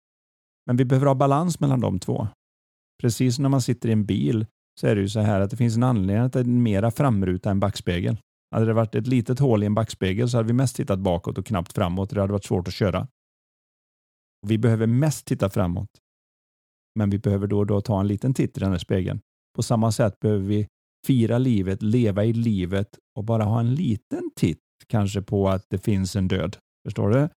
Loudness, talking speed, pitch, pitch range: -23 LUFS, 225 wpm, 110 Hz, 100-125 Hz